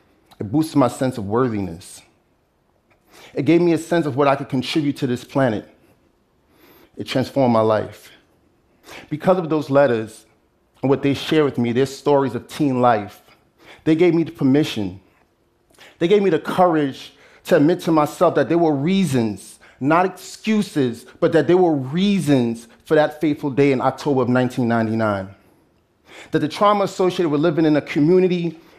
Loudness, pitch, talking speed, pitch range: -19 LUFS, 140 Hz, 165 wpm, 125-165 Hz